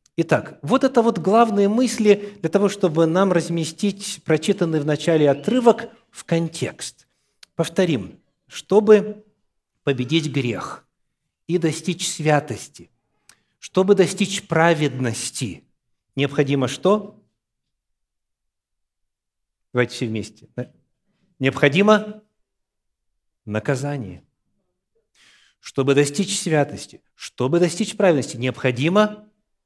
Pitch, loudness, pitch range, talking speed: 160 Hz, -20 LUFS, 130-200 Hz, 85 wpm